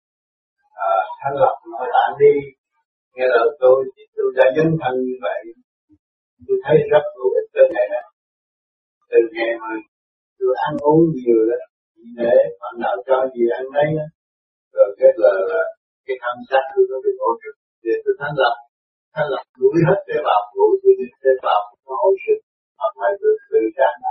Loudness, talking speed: -18 LUFS, 140 wpm